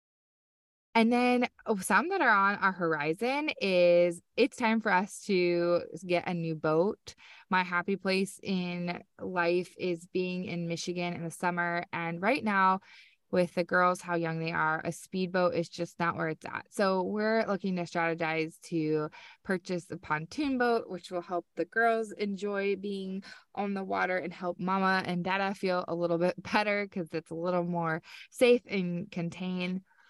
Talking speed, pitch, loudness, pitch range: 170 wpm, 180 Hz, -30 LUFS, 170-195 Hz